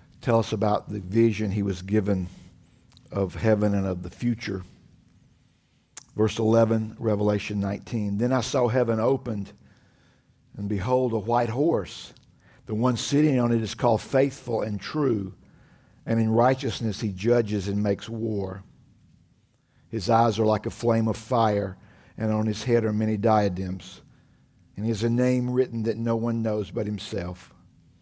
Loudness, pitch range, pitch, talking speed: -25 LUFS, 105-120 Hz, 110 Hz, 155 wpm